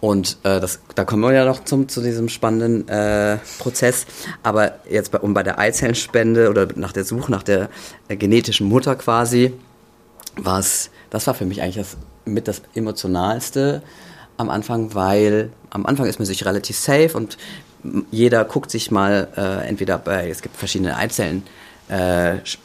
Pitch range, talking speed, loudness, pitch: 95-120 Hz, 165 wpm, -19 LUFS, 110 Hz